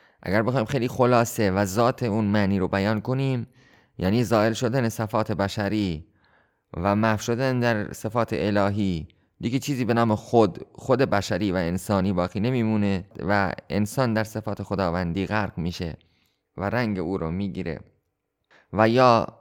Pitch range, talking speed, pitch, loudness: 100-120 Hz, 145 wpm, 105 Hz, -24 LUFS